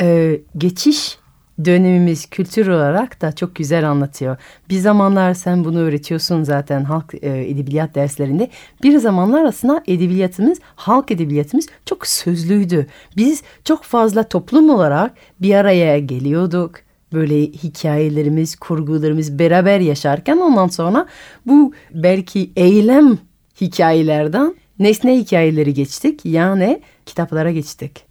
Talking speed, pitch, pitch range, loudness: 110 wpm, 175 Hz, 155-210 Hz, -15 LUFS